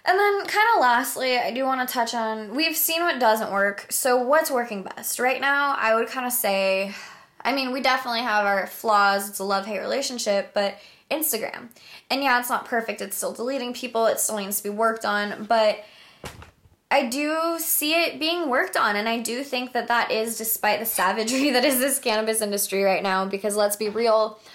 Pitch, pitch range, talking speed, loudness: 235 Hz, 210-265 Hz, 210 wpm, -23 LUFS